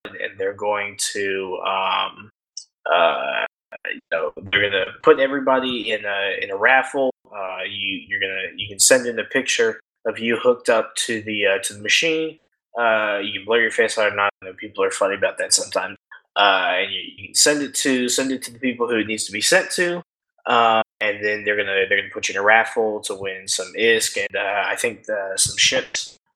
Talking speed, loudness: 220 wpm, -20 LUFS